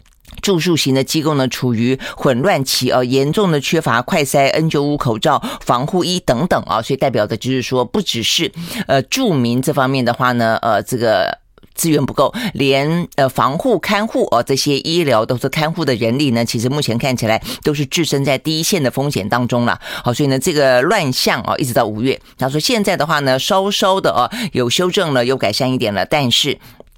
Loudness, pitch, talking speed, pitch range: -16 LUFS, 135 Hz, 305 characters per minute, 125-160 Hz